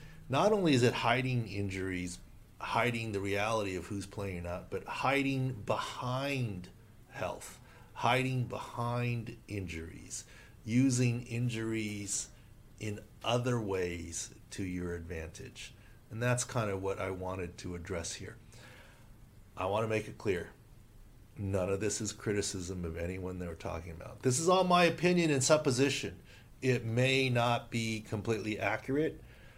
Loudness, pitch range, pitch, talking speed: -33 LUFS, 100-125 Hz, 110 Hz, 135 wpm